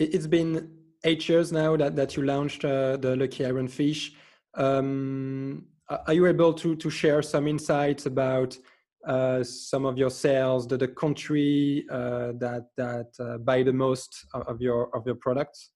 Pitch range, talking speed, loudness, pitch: 130-150 Hz, 170 wpm, -26 LUFS, 135 Hz